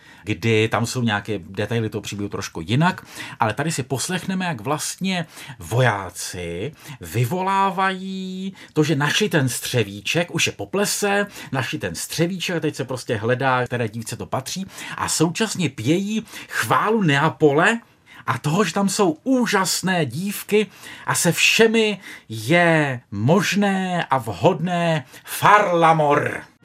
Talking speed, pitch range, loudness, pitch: 130 wpm, 125-190 Hz, -21 LUFS, 155 Hz